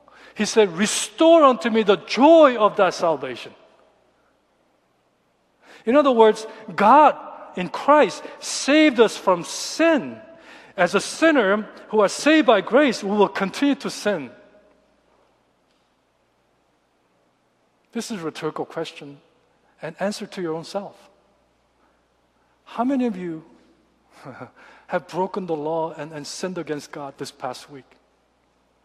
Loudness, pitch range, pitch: -19 LUFS, 160-250 Hz, 200 Hz